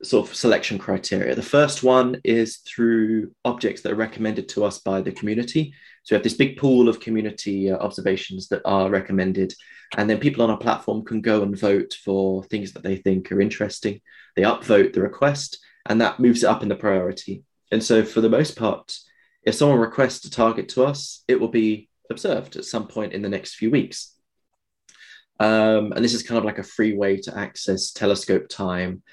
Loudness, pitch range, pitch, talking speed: -22 LUFS, 100-120 Hz, 110 Hz, 205 wpm